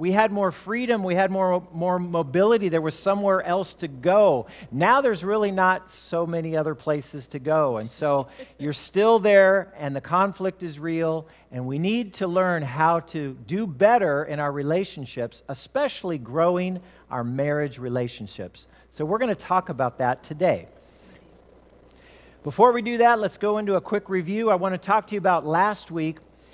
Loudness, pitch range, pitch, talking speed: -23 LUFS, 150-195 Hz, 175 Hz, 175 wpm